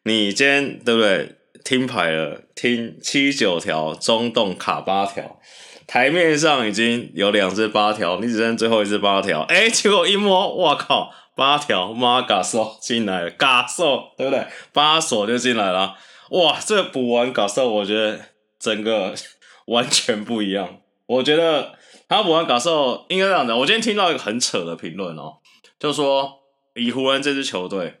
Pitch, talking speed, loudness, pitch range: 120 Hz, 245 characters per minute, -19 LUFS, 105-140 Hz